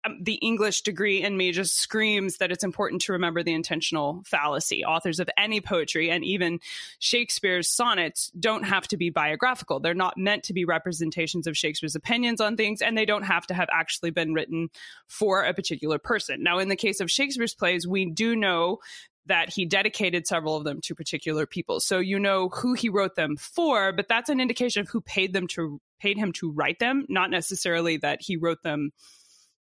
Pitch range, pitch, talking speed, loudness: 170-210 Hz, 185 Hz, 215 wpm, -25 LUFS